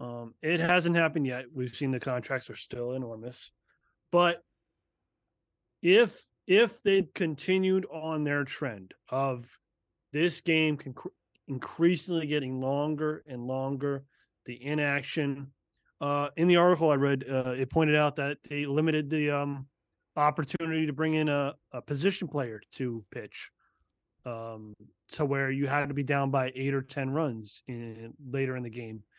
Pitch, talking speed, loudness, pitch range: 140 Hz, 150 wpm, -29 LUFS, 130-155 Hz